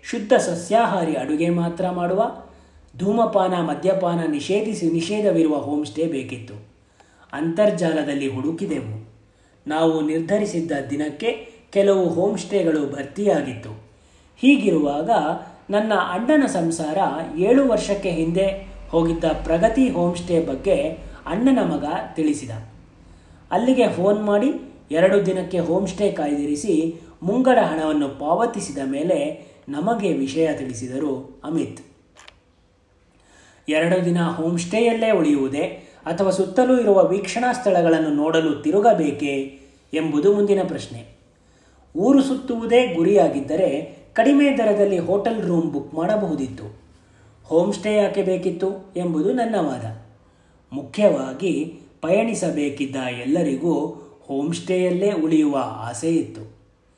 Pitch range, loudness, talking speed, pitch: 140-200 Hz, -21 LUFS, 95 wpm, 165 Hz